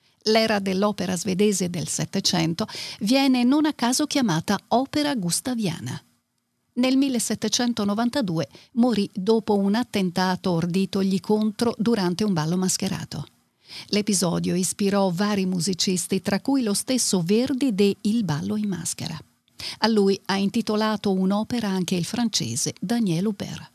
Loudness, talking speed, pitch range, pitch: -23 LUFS, 125 wpm, 180-225 Hz, 200 Hz